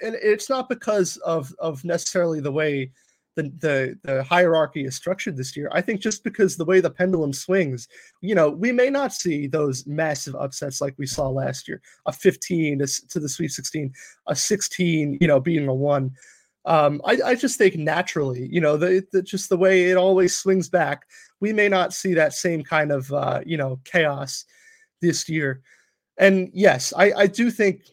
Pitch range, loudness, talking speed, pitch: 145-190 Hz, -22 LUFS, 195 wpm, 170 Hz